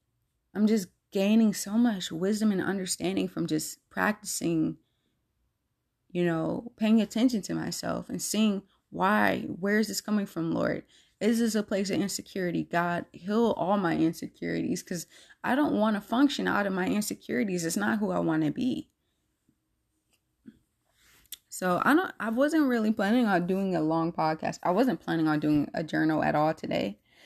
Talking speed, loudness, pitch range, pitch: 165 wpm, -28 LUFS, 170-220 Hz, 200 Hz